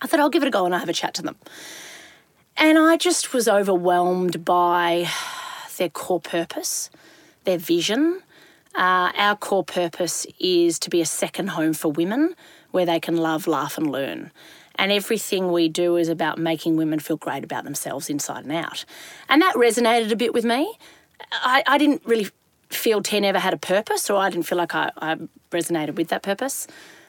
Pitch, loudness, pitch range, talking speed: 190 Hz, -22 LUFS, 170-270 Hz, 195 wpm